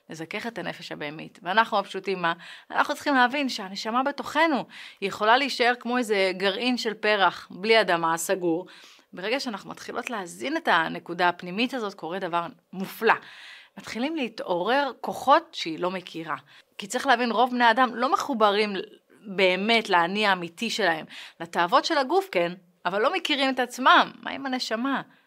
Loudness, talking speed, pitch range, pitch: -25 LUFS, 150 wpm, 185-255 Hz, 220 Hz